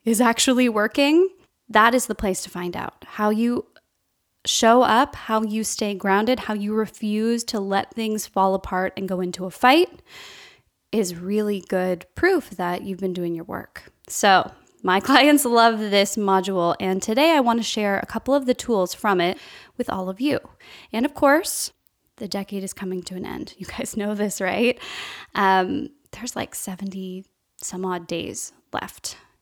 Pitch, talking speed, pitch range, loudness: 215 Hz, 175 wpm, 190-245 Hz, -22 LUFS